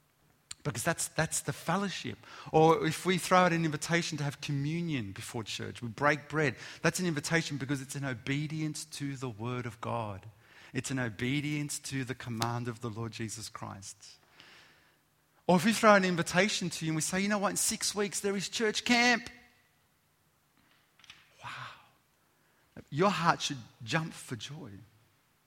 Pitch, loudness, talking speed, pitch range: 145 Hz, -31 LUFS, 170 wpm, 120-170 Hz